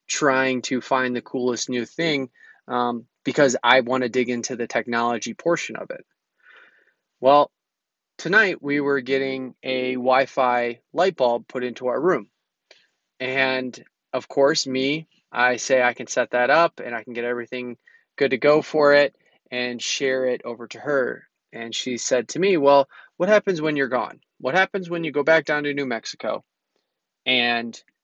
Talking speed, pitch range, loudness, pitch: 175 wpm, 120-140 Hz, -22 LUFS, 130 Hz